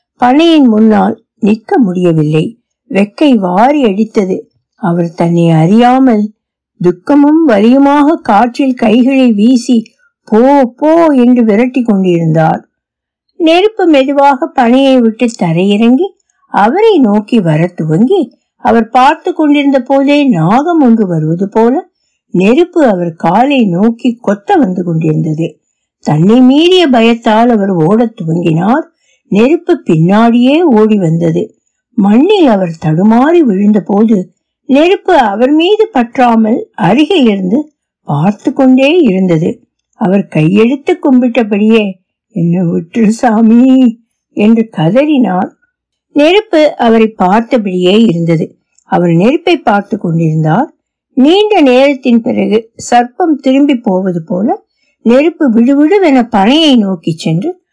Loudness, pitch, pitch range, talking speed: -8 LUFS, 235 Hz, 195-280 Hz, 100 wpm